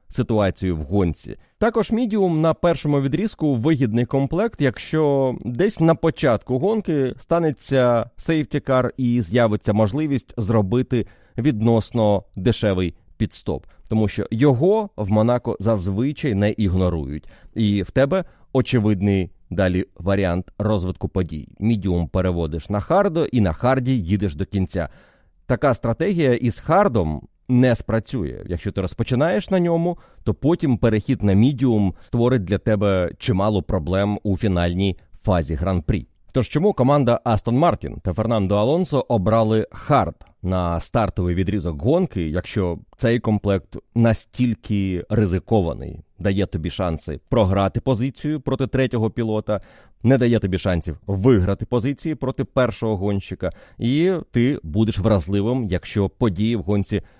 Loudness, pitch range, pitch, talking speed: -21 LUFS, 95-130 Hz, 110 Hz, 125 wpm